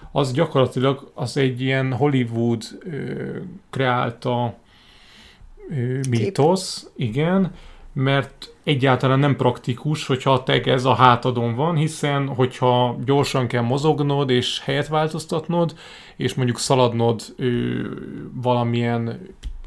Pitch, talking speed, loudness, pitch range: 130 Hz, 110 wpm, -21 LUFS, 120-145 Hz